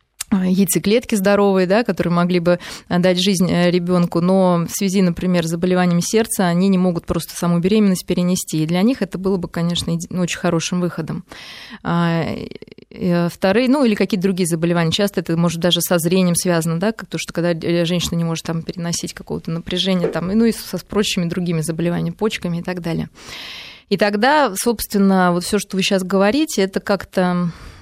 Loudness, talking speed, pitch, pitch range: -18 LUFS, 175 wpm, 180 Hz, 170-200 Hz